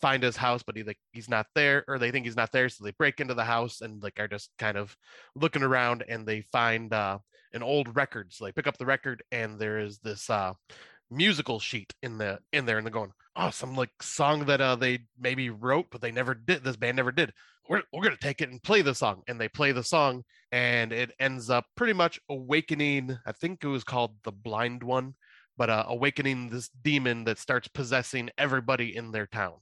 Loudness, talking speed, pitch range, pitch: -29 LUFS, 230 wpm, 110-135 Hz, 125 Hz